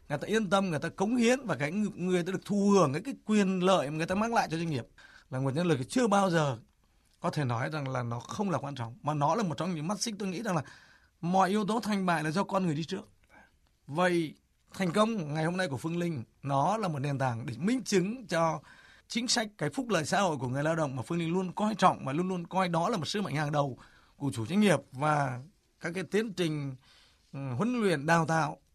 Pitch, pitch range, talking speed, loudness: 170 Hz, 145-195 Hz, 265 wpm, -30 LUFS